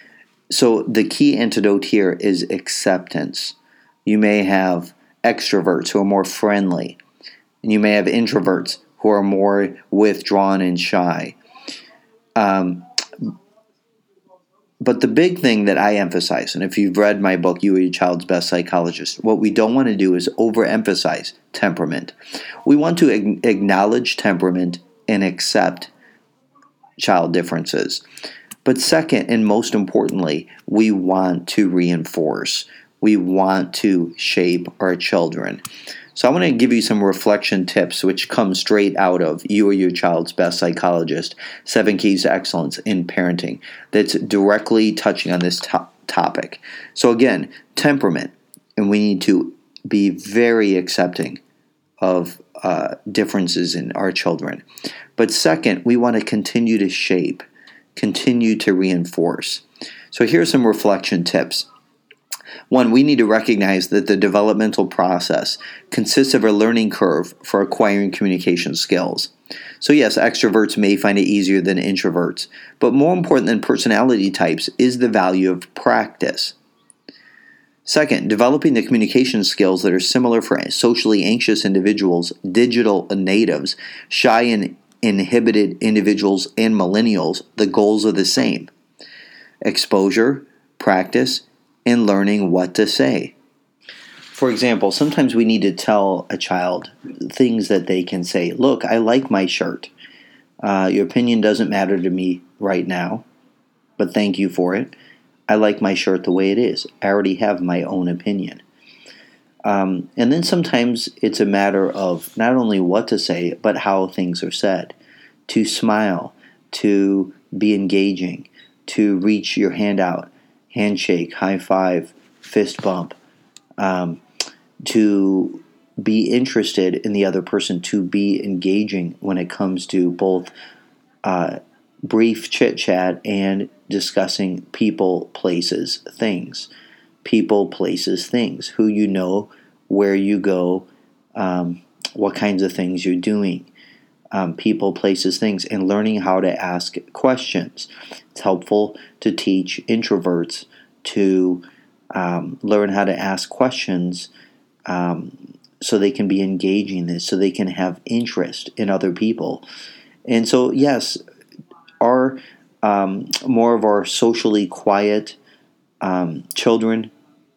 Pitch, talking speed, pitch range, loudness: 100 Hz, 135 wpm, 90-110 Hz, -18 LUFS